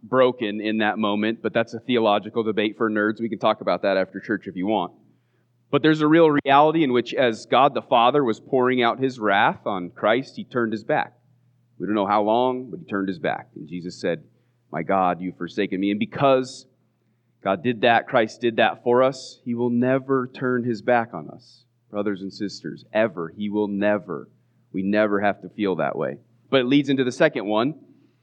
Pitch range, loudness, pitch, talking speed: 105-125 Hz, -22 LUFS, 120 Hz, 215 wpm